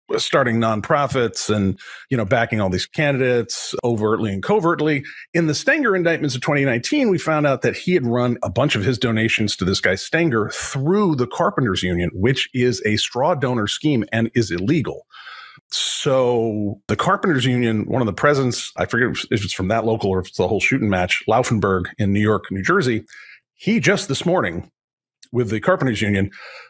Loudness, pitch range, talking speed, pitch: -19 LUFS, 105-145 Hz, 185 wpm, 120 Hz